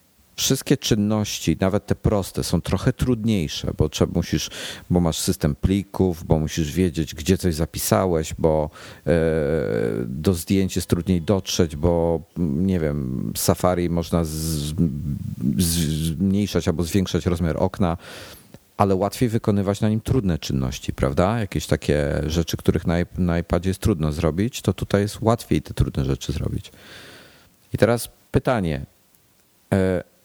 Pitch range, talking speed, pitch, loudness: 80-100 Hz, 140 wpm, 90 Hz, -22 LUFS